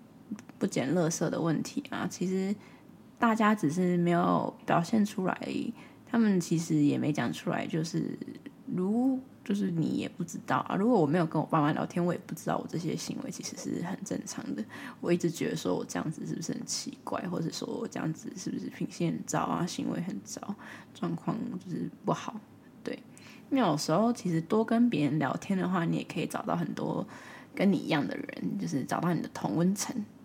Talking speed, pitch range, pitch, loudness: 300 characters per minute, 170-240 Hz, 200 Hz, -31 LUFS